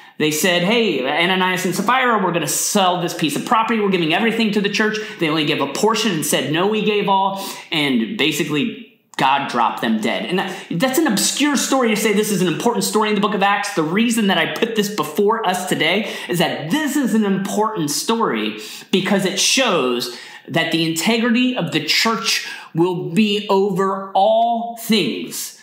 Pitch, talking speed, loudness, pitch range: 200 Hz, 200 wpm, -18 LUFS, 175-225 Hz